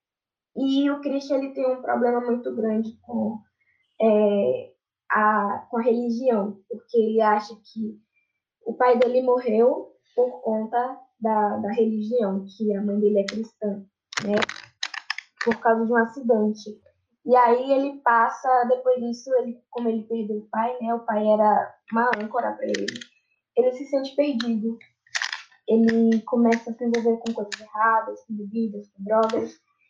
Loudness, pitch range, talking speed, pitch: -24 LUFS, 215-250 Hz, 155 wpm, 230 Hz